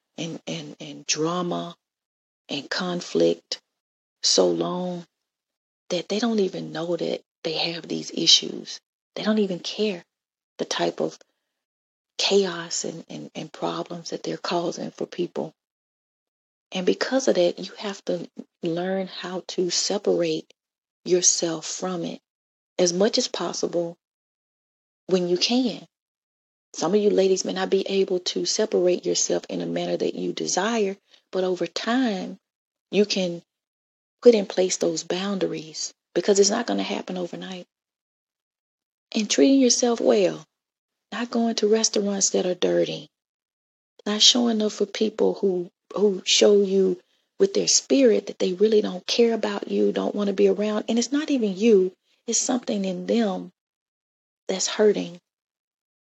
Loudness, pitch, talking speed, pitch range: -23 LUFS, 190 Hz, 145 wpm, 170-215 Hz